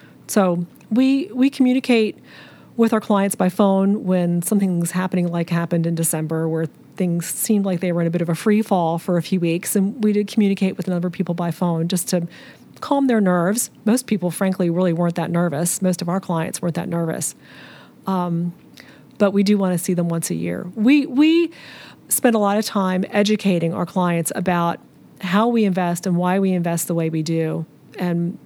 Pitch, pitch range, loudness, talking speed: 185 Hz, 170-205 Hz, -20 LUFS, 205 wpm